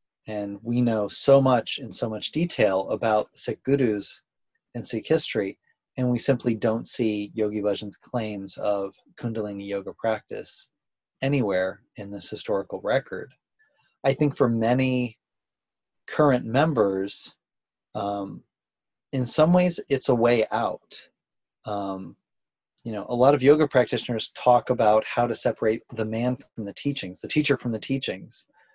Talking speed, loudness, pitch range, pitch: 145 wpm, -25 LUFS, 105-135 Hz, 120 Hz